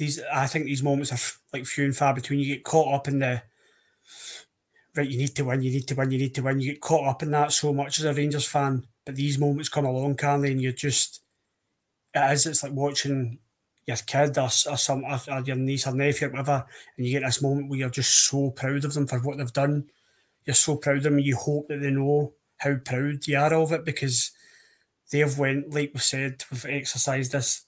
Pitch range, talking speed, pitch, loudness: 135-145 Hz, 245 wpm, 140 Hz, -24 LUFS